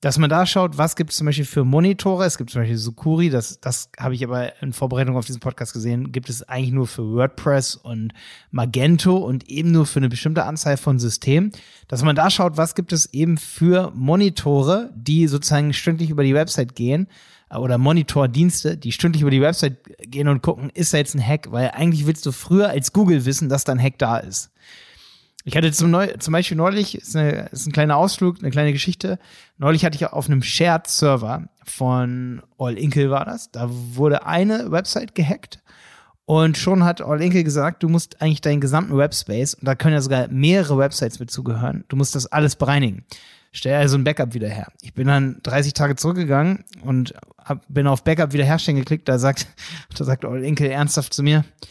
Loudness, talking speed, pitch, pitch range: -19 LUFS, 200 wpm, 145 Hz, 130-165 Hz